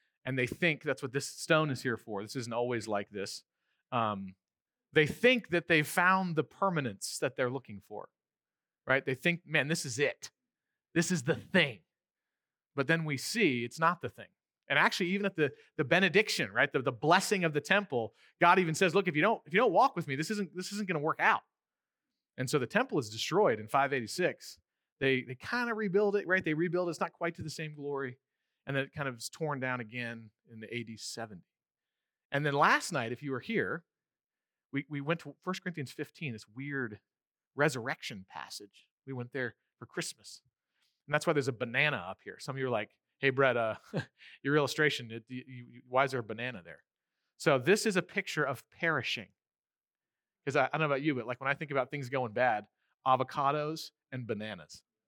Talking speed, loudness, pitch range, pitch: 210 wpm, -32 LUFS, 125-170 Hz, 140 Hz